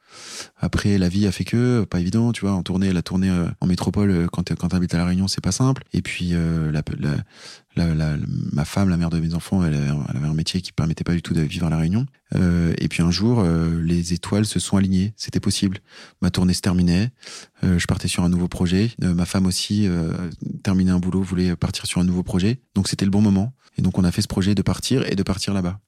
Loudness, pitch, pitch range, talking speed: -21 LUFS, 90 Hz, 85-100 Hz, 260 wpm